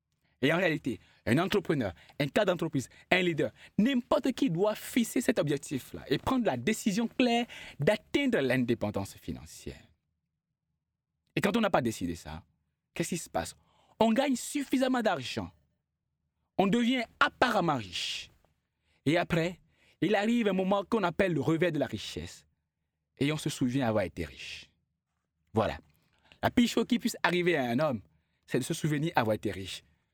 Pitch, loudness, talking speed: 150 Hz, -30 LUFS, 160 wpm